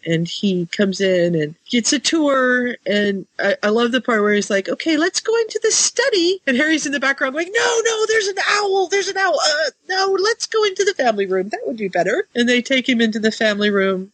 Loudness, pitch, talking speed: -17 LUFS, 260 Hz, 240 wpm